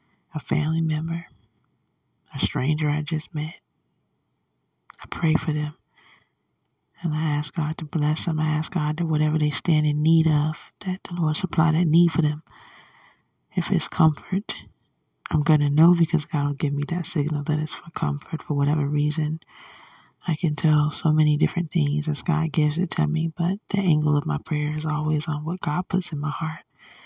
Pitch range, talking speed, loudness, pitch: 150-165 Hz, 190 wpm, -24 LUFS, 155 Hz